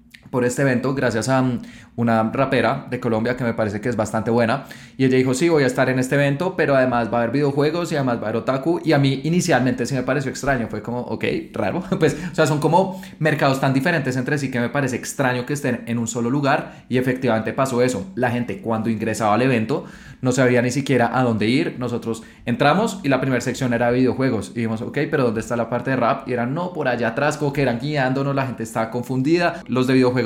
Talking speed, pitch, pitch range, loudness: 240 wpm, 130 Hz, 120-140 Hz, -20 LUFS